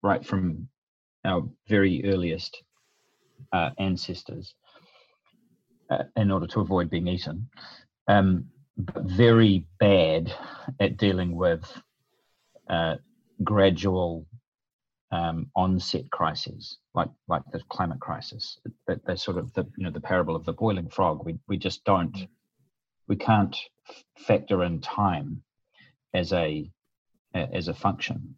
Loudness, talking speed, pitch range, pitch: -26 LUFS, 120 wpm, 90-105 Hz, 95 Hz